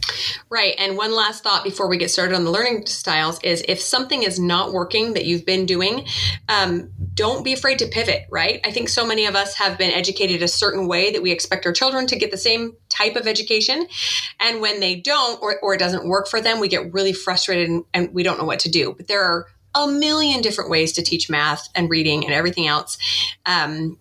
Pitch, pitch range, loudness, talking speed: 190 Hz, 175-215 Hz, -19 LUFS, 230 wpm